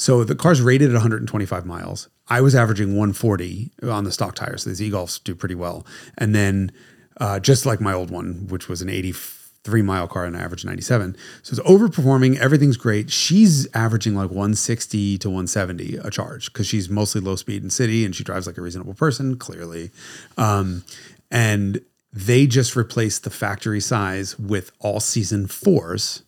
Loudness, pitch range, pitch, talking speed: -20 LUFS, 95-125 Hz, 105 Hz, 185 wpm